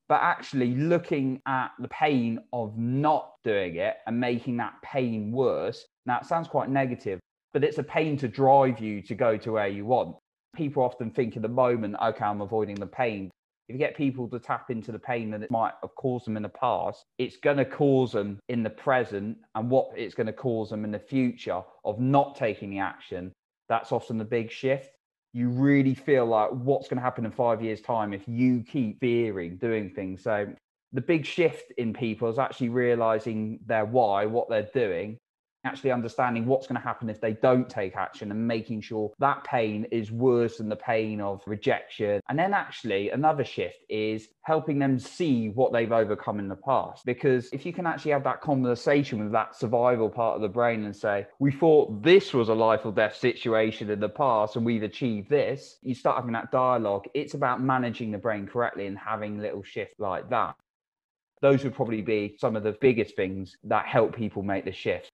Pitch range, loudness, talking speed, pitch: 110-130 Hz, -27 LUFS, 205 wpm, 120 Hz